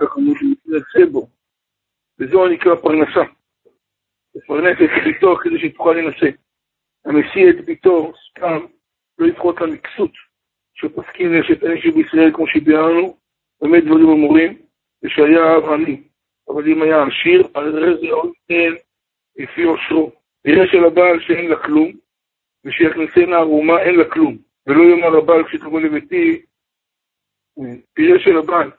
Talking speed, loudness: 135 wpm, -14 LUFS